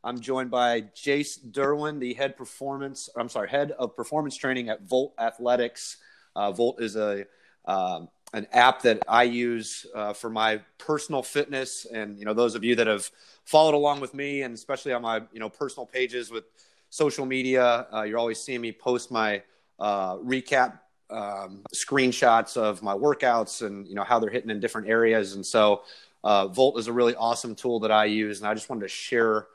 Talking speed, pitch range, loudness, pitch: 195 wpm, 110-130 Hz, -26 LUFS, 120 Hz